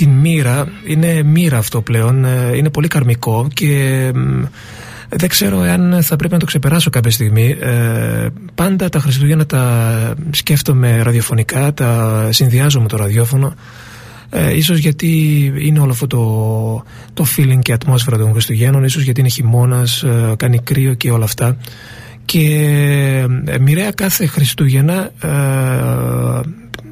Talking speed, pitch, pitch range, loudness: 135 wpm, 130 Hz, 115-150 Hz, -13 LUFS